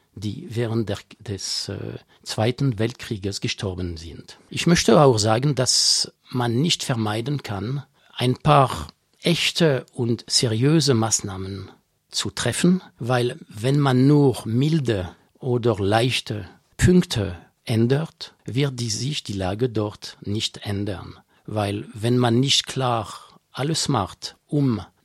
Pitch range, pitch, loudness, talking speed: 105-135 Hz, 120 Hz, -22 LUFS, 120 wpm